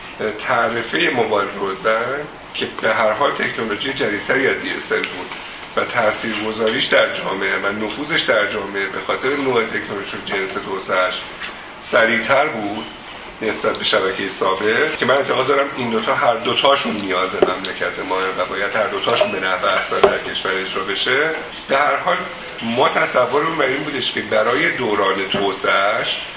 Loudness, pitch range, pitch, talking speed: -18 LUFS, 95-110 Hz, 100 Hz, 150 wpm